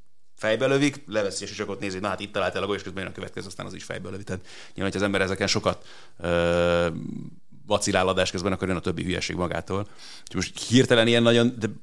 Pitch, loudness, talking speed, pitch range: 95 Hz, -25 LUFS, 215 wpm, 95-105 Hz